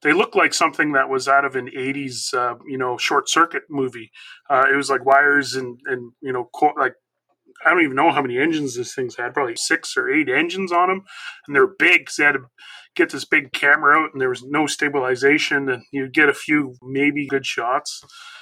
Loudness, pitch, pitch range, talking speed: -19 LUFS, 140 Hz, 130-175 Hz, 225 wpm